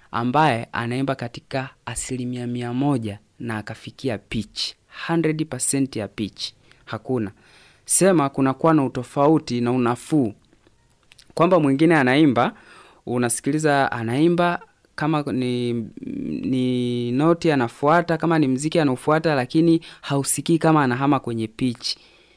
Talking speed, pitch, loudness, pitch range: 105 wpm, 130 Hz, -21 LUFS, 120-155 Hz